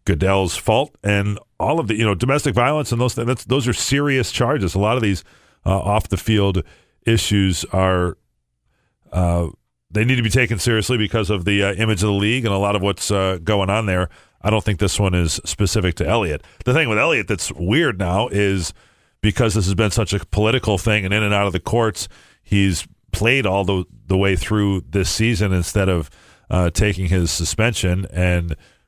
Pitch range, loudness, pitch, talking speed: 95-110 Hz, -19 LUFS, 100 Hz, 205 wpm